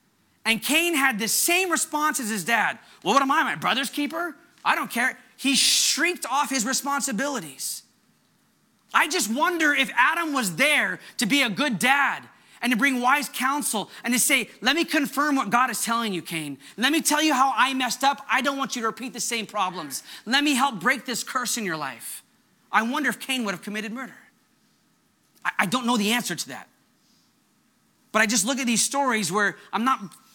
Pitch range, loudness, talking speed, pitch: 225-280 Hz, -23 LUFS, 205 wpm, 255 Hz